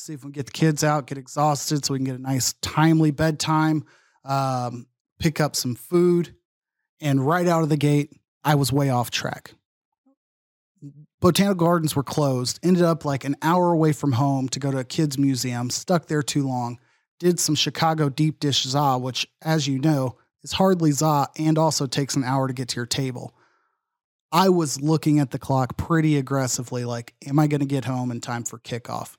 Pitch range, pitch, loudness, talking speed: 130-160 Hz, 145 Hz, -22 LUFS, 200 wpm